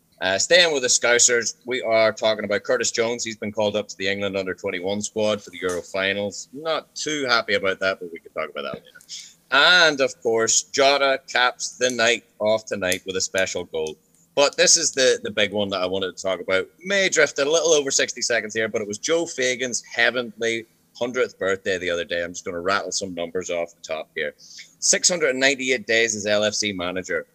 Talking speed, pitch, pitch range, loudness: 215 wpm, 110 Hz, 100-130 Hz, -21 LUFS